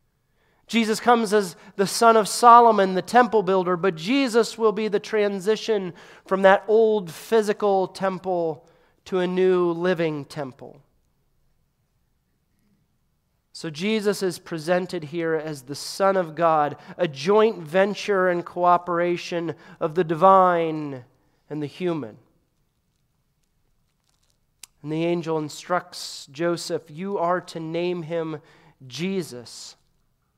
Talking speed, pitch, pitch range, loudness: 115 wpm, 180 Hz, 165-200 Hz, -22 LUFS